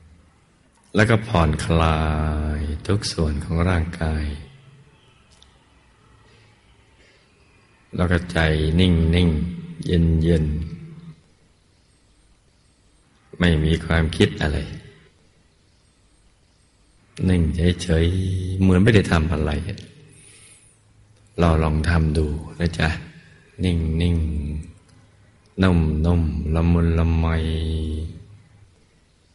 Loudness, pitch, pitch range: -21 LUFS, 85 Hz, 80-100 Hz